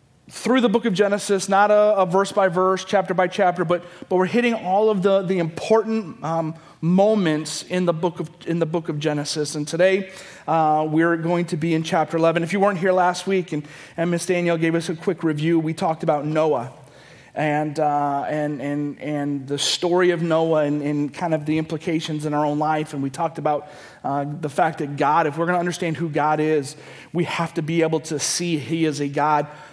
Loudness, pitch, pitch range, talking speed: -21 LUFS, 165 Hz, 150-180 Hz, 220 wpm